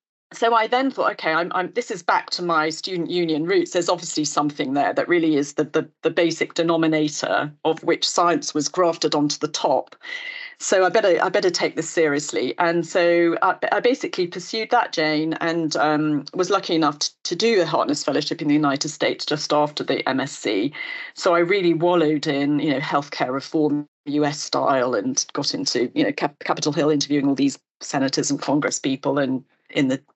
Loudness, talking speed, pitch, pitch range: -21 LUFS, 195 wpm, 160 Hz, 150-185 Hz